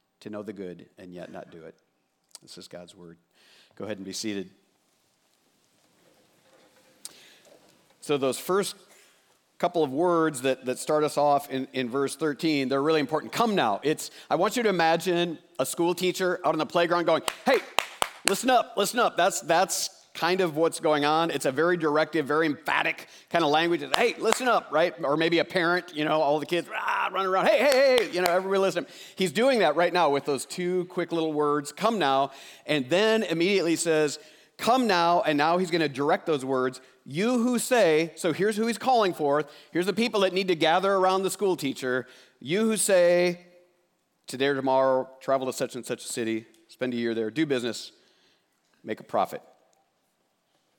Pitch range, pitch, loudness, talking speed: 140-185 Hz, 160 Hz, -25 LUFS, 195 wpm